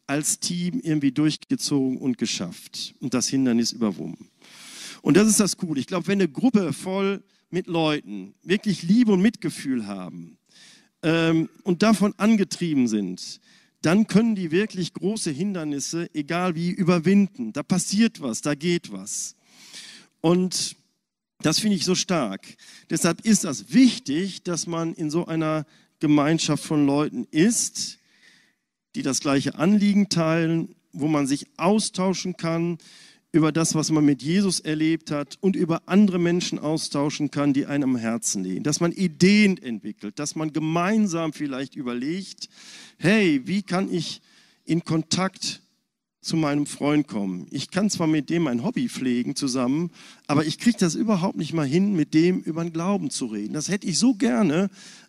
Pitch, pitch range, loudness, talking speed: 170 Hz, 150-205 Hz, -23 LUFS, 160 wpm